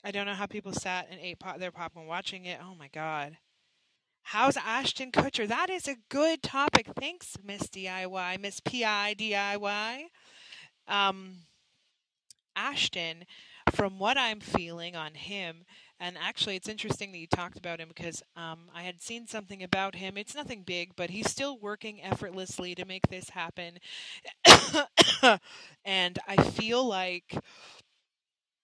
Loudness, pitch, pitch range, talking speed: -28 LUFS, 190 Hz, 175-215 Hz, 145 wpm